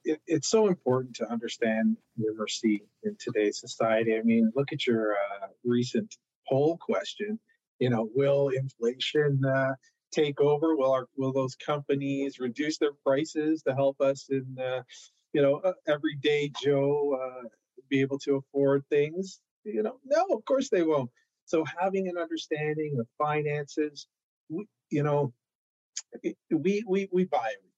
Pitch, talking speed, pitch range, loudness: 140 Hz, 155 wpm, 130-155 Hz, -29 LUFS